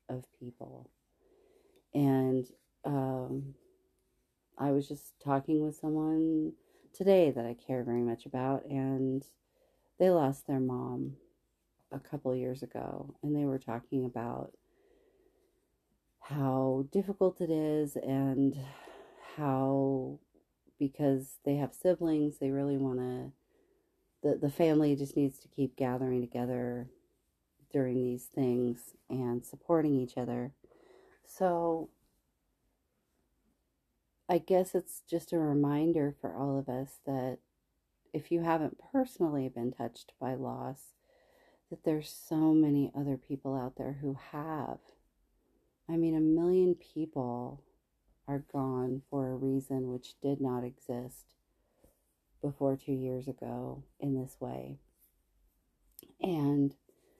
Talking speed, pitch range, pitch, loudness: 120 wpm, 130-160 Hz, 140 Hz, -33 LUFS